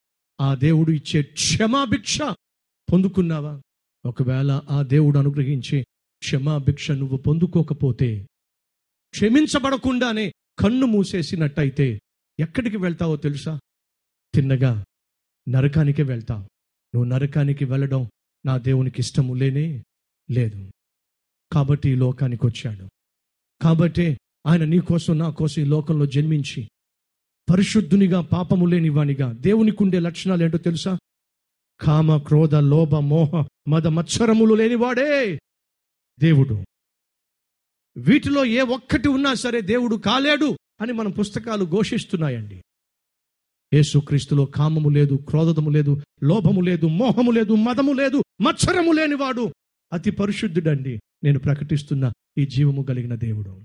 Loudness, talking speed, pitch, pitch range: -20 LUFS, 100 wpm, 155 Hz, 140-195 Hz